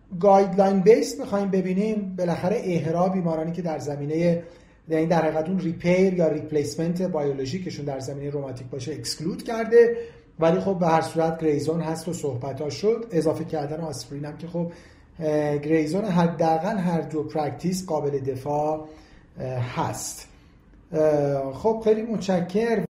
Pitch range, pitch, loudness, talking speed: 150-185 Hz, 160 Hz, -24 LUFS, 135 wpm